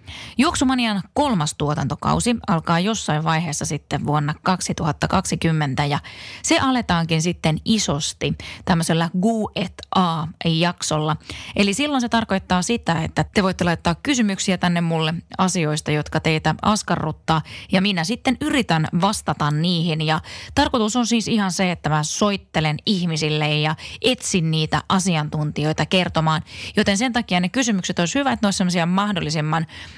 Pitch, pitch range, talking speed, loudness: 175 Hz, 155-210 Hz, 130 wpm, -21 LUFS